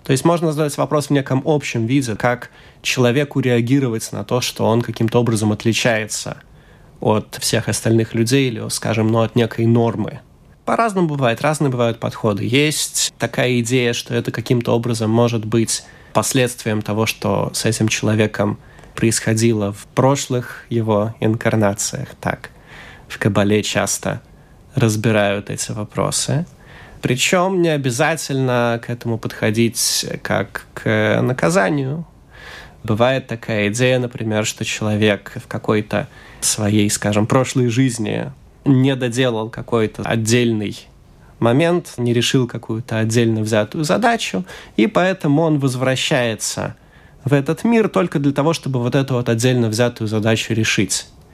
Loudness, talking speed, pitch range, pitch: -18 LUFS, 130 wpm, 110-135 Hz, 120 Hz